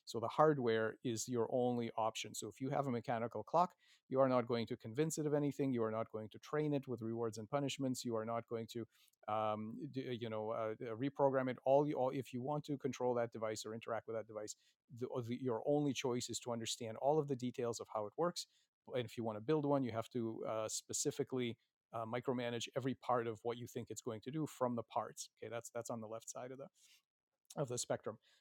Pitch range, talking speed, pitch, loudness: 115-135 Hz, 245 wpm, 120 Hz, -40 LUFS